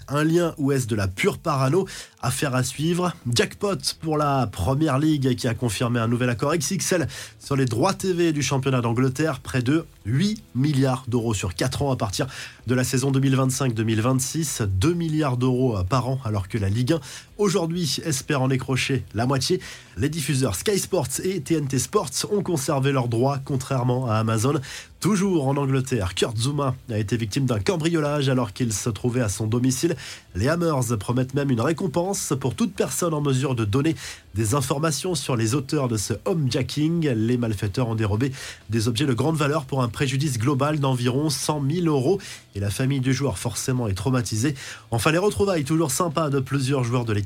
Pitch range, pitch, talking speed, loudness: 125-155 Hz, 135 Hz, 185 wpm, -23 LUFS